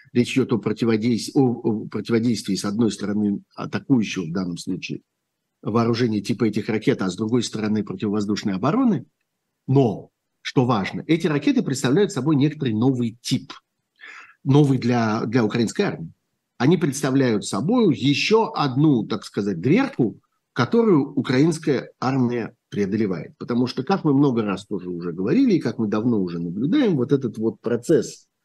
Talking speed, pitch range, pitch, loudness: 150 wpm, 110-145 Hz, 120 Hz, -22 LUFS